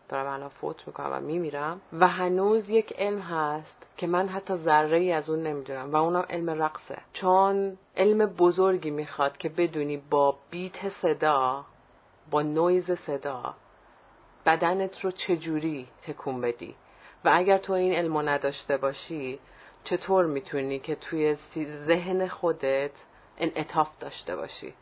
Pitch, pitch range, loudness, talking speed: 160 Hz, 145-185 Hz, -27 LUFS, 135 wpm